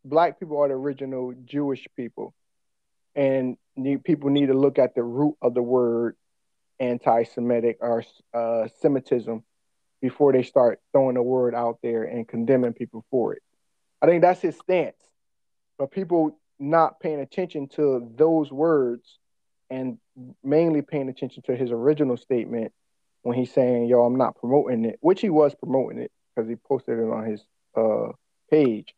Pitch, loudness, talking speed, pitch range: 130 Hz, -24 LUFS, 160 wpm, 120-145 Hz